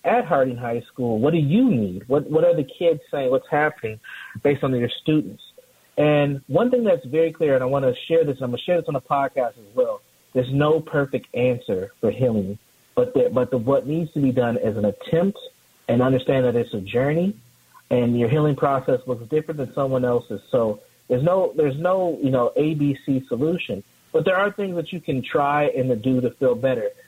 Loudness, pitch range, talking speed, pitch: -22 LUFS, 125-165 Hz, 220 wpm, 140 Hz